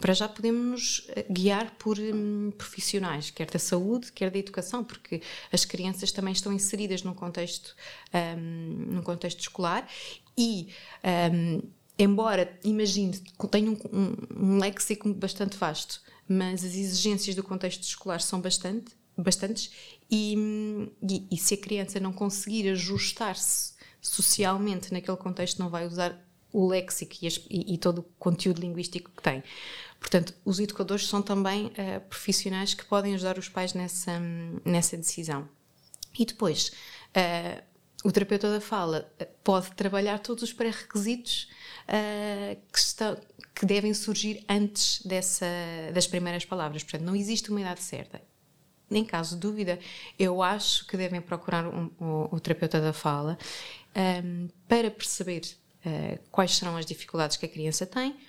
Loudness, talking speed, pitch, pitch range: -29 LUFS, 145 wpm, 190 Hz, 175-205 Hz